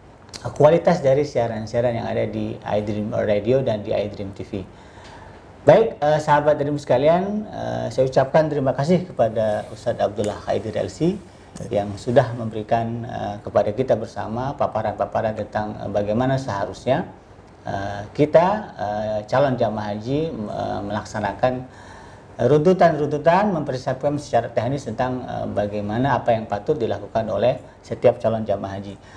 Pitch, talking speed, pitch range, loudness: 115 Hz, 130 wpm, 105-140 Hz, -21 LUFS